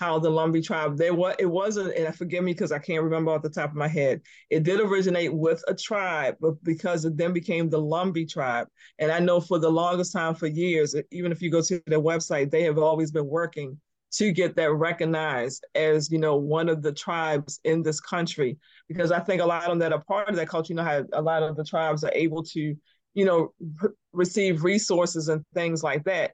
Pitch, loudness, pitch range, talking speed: 165 Hz, -25 LUFS, 155-175 Hz, 235 wpm